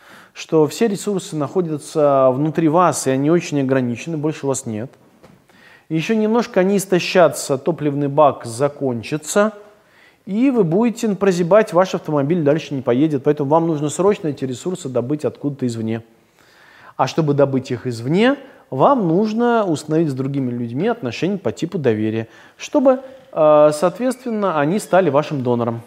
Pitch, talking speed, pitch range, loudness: 155 Hz, 140 wpm, 135-195 Hz, -18 LUFS